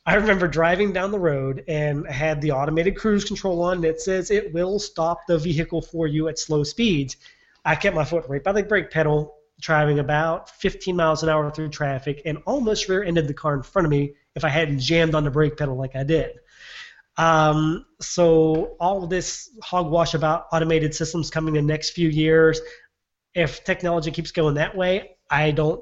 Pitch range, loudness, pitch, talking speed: 155-180 Hz, -22 LUFS, 160 Hz, 200 wpm